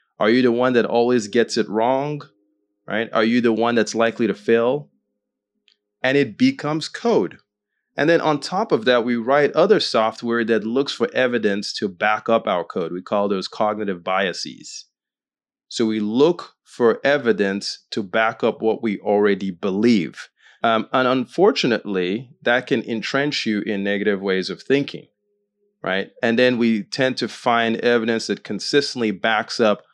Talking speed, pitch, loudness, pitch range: 165 wpm, 115 Hz, -20 LUFS, 105-130 Hz